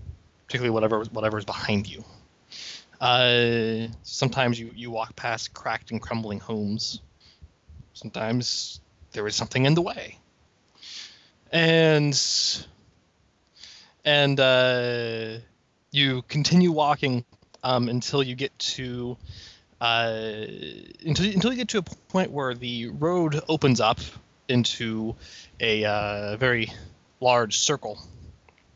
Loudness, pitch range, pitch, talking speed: -24 LUFS, 110-135 Hz, 115 Hz, 110 wpm